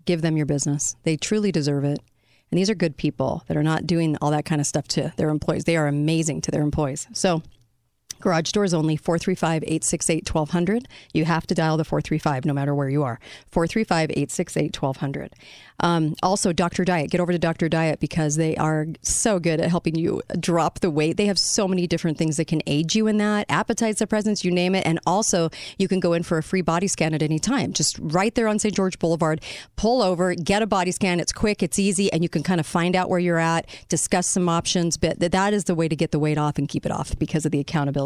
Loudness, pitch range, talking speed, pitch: -22 LUFS, 155-185 Hz, 235 wpm, 165 Hz